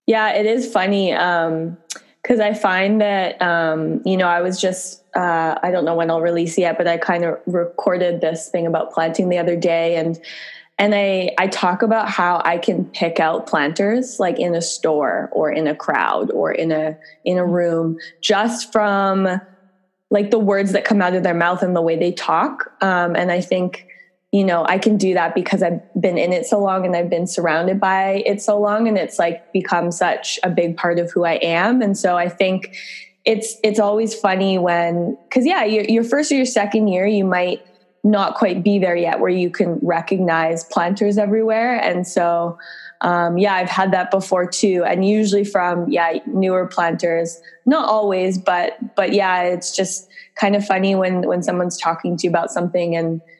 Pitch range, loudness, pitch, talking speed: 170-205 Hz, -18 LUFS, 185 Hz, 200 wpm